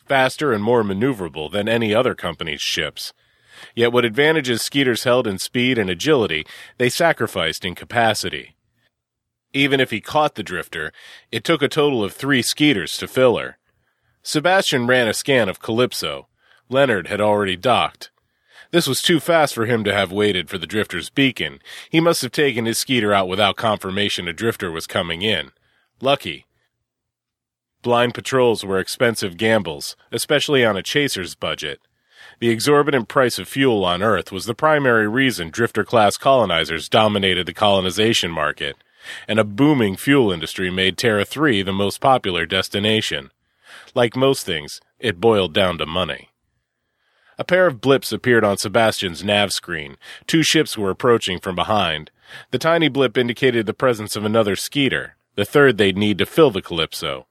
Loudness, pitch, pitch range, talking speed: -19 LUFS, 115 Hz, 100-135 Hz, 165 wpm